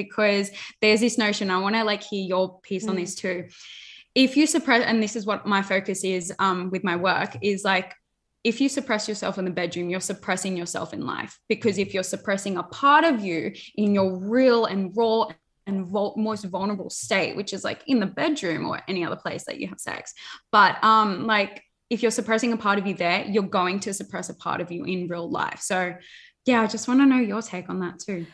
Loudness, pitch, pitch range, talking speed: -24 LUFS, 200 Hz, 185-225 Hz, 225 wpm